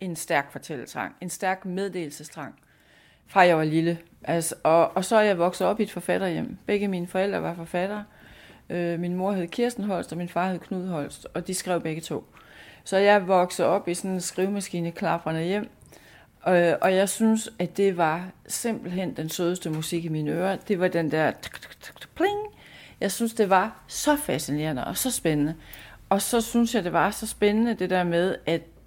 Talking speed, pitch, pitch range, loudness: 195 wpm, 180 Hz, 165-200 Hz, -25 LUFS